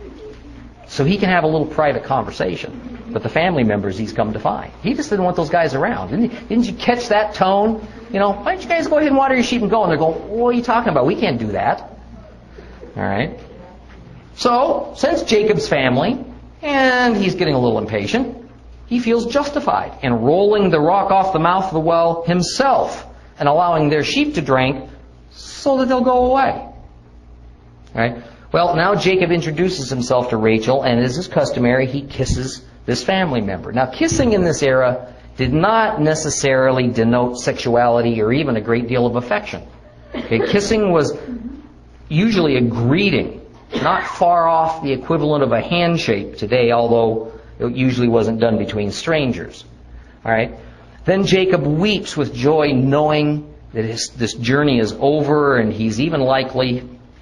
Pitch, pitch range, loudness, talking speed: 150 Hz, 120-205 Hz, -17 LUFS, 175 wpm